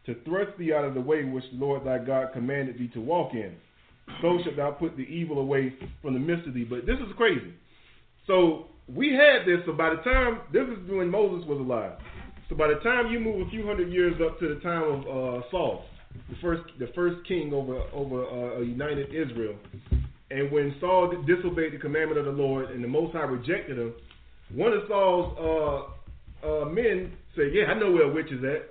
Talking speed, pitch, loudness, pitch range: 220 wpm, 155 Hz, -27 LUFS, 130-180 Hz